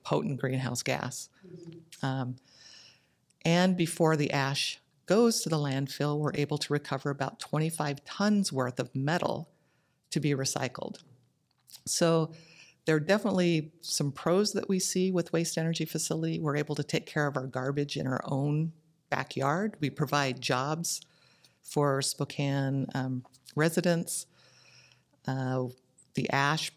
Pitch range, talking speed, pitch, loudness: 135-165 Hz, 135 wpm, 150 Hz, -30 LUFS